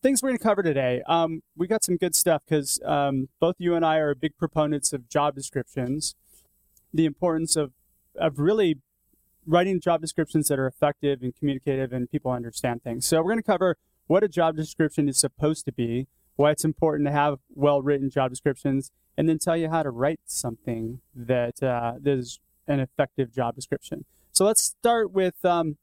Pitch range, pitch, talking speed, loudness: 135-165 Hz, 145 Hz, 195 wpm, -25 LUFS